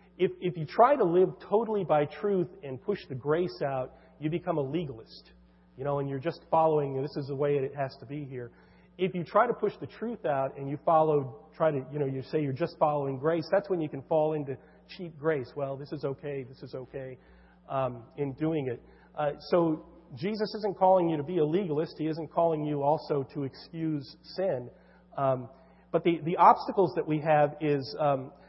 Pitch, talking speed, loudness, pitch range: 155 Hz, 215 wpm, -29 LUFS, 140-170 Hz